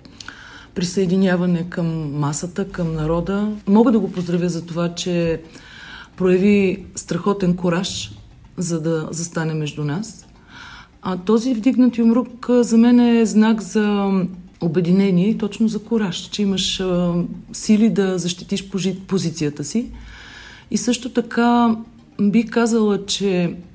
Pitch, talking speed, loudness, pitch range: 190 Hz, 120 wpm, -19 LUFS, 175-220 Hz